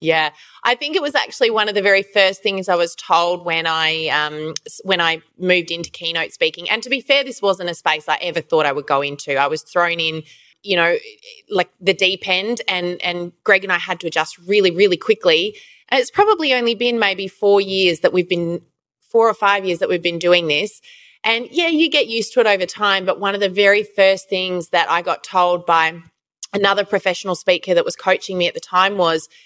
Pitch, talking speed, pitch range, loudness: 185 Hz, 230 wpm, 170-210 Hz, -17 LUFS